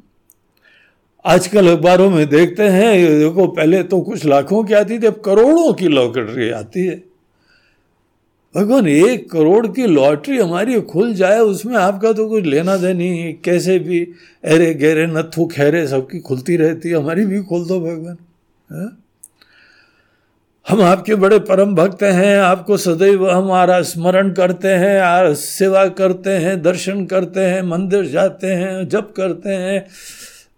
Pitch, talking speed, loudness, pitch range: 185 Hz, 145 wpm, -14 LUFS, 170-195 Hz